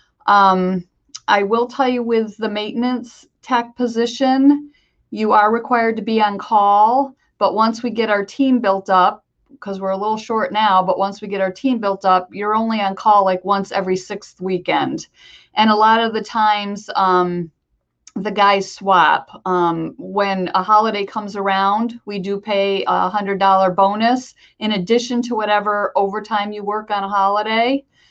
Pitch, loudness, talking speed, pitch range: 210 Hz, -17 LUFS, 170 wpm, 195-225 Hz